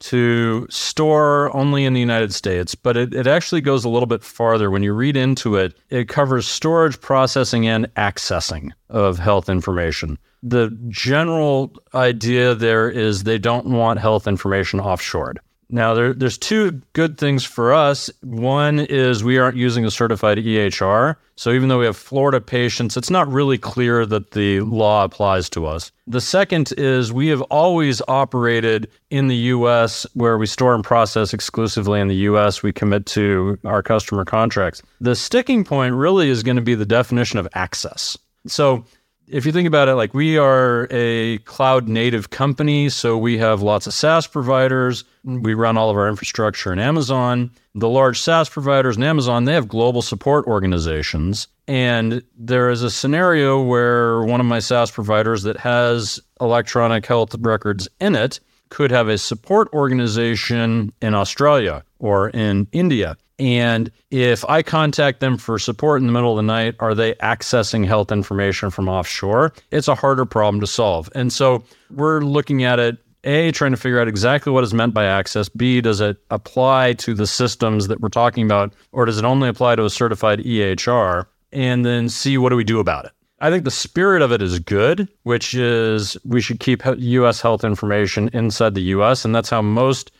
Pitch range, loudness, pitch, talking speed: 110-130 Hz, -18 LUFS, 120 Hz, 180 wpm